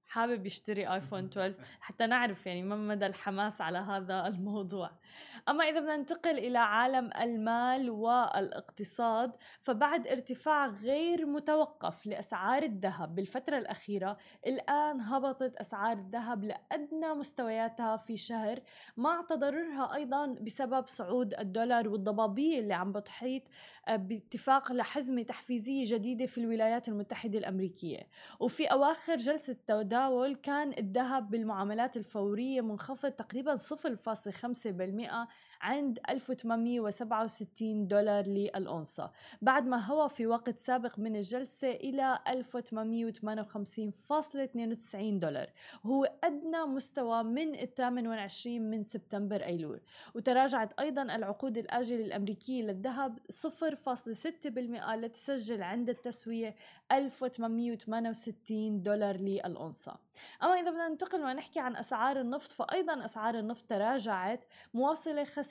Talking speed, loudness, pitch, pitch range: 105 wpm, -35 LUFS, 235 Hz, 215-270 Hz